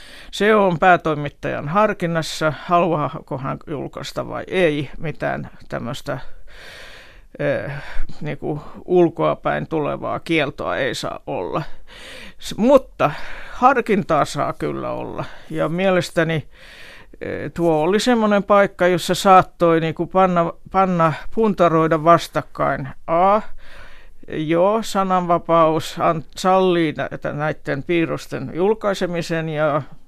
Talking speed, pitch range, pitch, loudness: 100 wpm, 160-190 Hz, 170 Hz, -19 LUFS